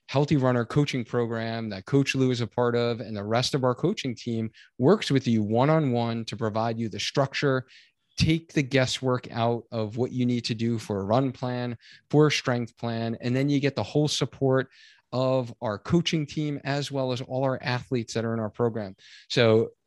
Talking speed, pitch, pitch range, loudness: 210 wpm, 125 Hz, 115-140 Hz, -26 LUFS